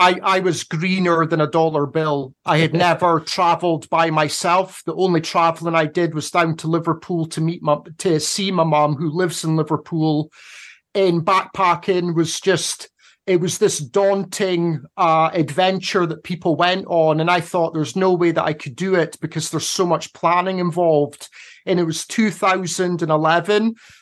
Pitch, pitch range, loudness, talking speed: 170 Hz, 160-180 Hz, -19 LUFS, 170 wpm